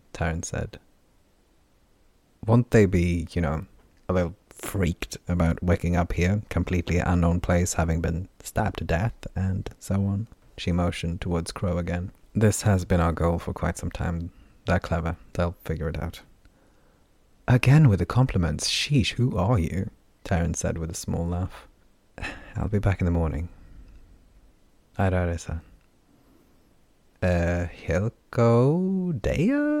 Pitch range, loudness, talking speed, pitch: 85-100 Hz, -25 LUFS, 145 wpm, 90 Hz